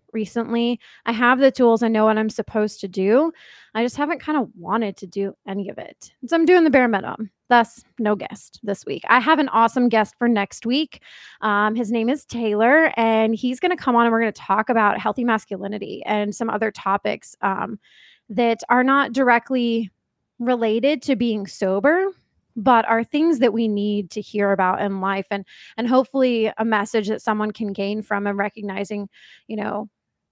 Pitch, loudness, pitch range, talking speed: 225 Hz, -20 LUFS, 210-245 Hz, 195 wpm